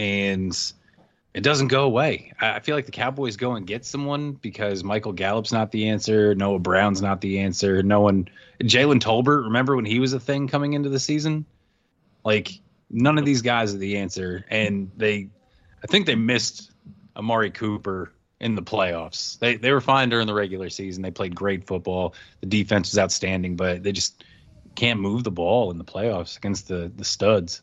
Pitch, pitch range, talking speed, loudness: 105 Hz, 95-125 Hz, 190 wpm, -23 LUFS